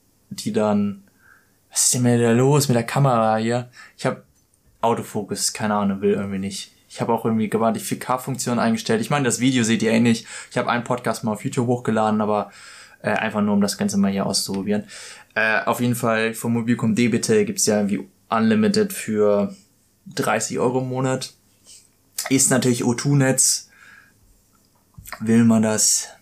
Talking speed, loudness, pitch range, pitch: 175 wpm, -20 LUFS, 105-125 Hz, 115 Hz